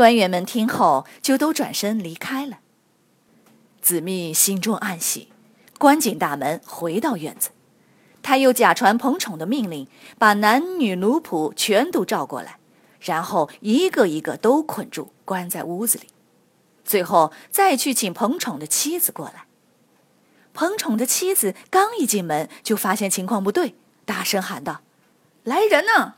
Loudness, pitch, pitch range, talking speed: -20 LUFS, 225 Hz, 190-275 Hz, 220 characters per minute